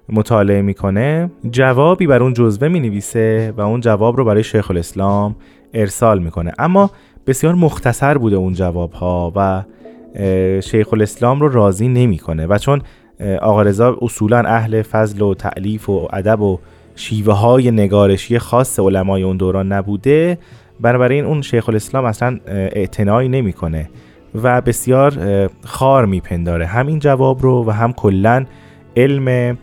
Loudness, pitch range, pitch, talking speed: -15 LUFS, 95-125 Hz, 110 Hz, 140 wpm